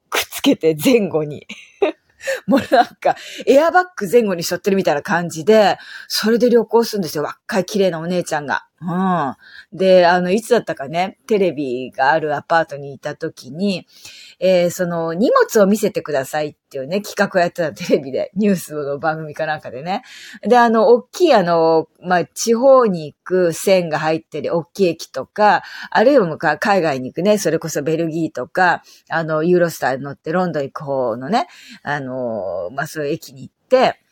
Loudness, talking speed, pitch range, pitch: -17 LUFS, 370 characters per minute, 155-205 Hz, 175 Hz